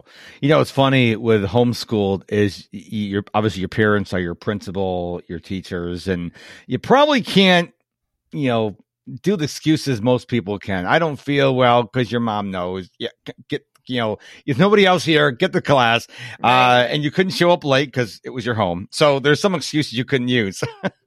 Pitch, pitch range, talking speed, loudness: 120 Hz, 100-145 Hz, 190 wpm, -18 LUFS